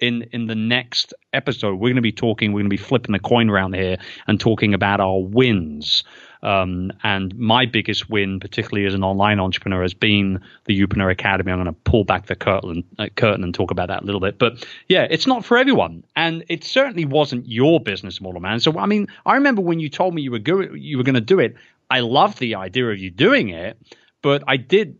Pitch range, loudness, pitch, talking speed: 95-130 Hz, -19 LUFS, 110 Hz, 230 wpm